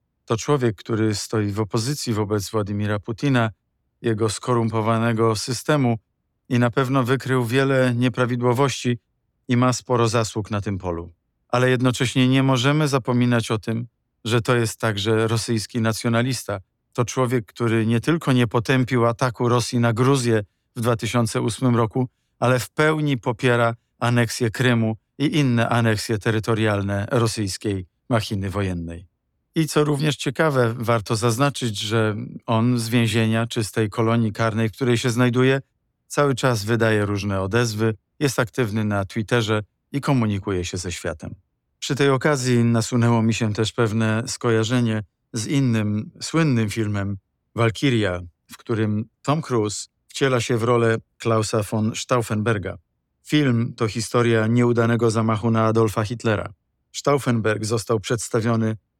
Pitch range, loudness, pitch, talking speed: 110-125 Hz, -21 LUFS, 115 Hz, 135 wpm